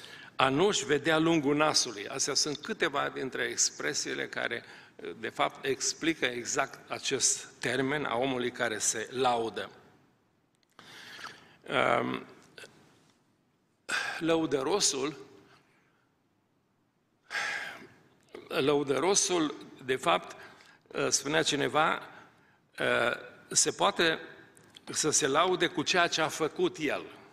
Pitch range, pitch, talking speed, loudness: 140-185 Hz, 155 Hz, 85 wpm, -29 LUFS